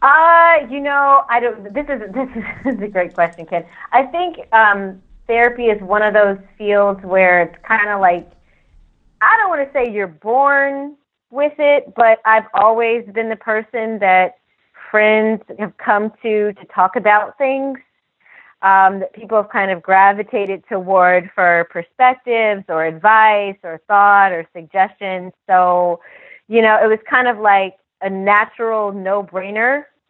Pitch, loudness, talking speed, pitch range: 210 Hz, -15 LUFS, 155 wpm, 190-235 Hz